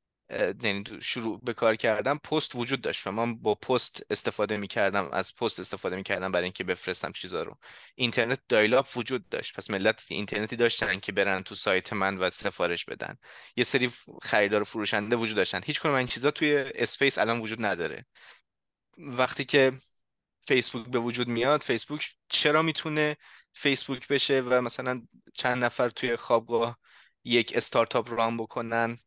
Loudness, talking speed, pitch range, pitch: -27 LUFS, 160 wpm, 110-135 Hz, 120 Hz